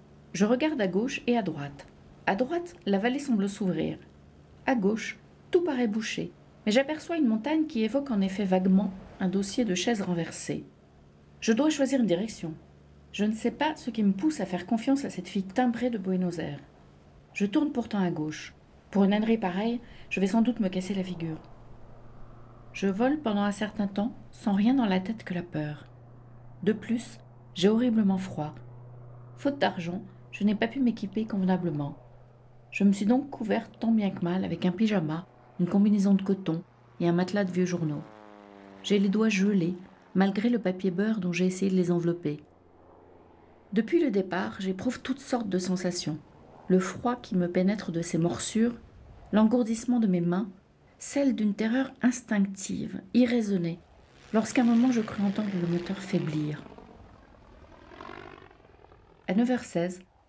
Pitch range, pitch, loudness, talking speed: 165-230 Hz, 195 Hz, -28 LUFS, 170 wpm